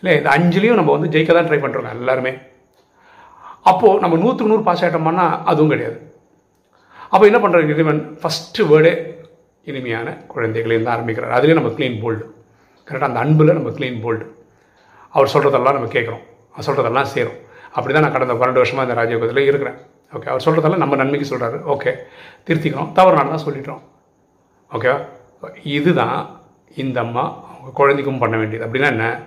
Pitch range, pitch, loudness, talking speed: 125-165 Hz, 150 Hz, -16 LUFS, 155 wpm